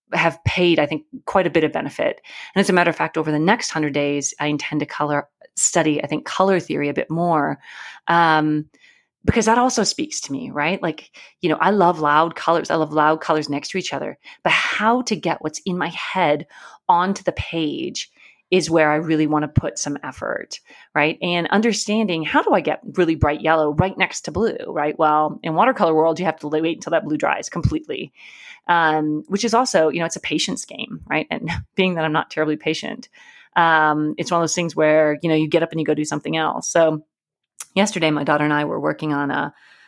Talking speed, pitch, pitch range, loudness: 225 wpm, 160 Hz, 150-180 Hz, -20 LUFS